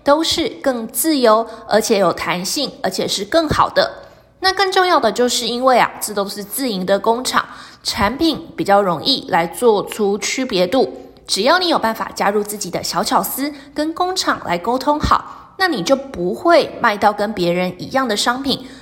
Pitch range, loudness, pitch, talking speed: 205-285 Hz, -17 LUFS, 240 Hz, 260 characters per minute